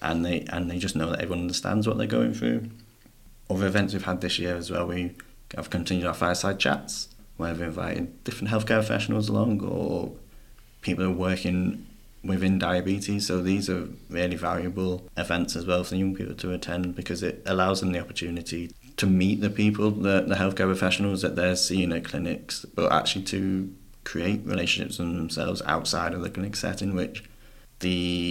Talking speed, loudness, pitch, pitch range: 185 wpm, -27 LUFS, 95 Hz, 90-100 Hz